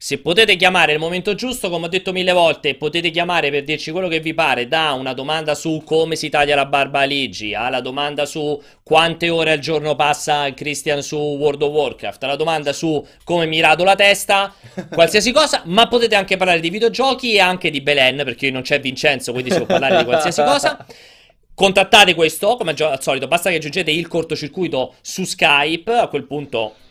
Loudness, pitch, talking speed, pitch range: -16 LUFS, 155 Hz, 200 wpm, 145-180 Hz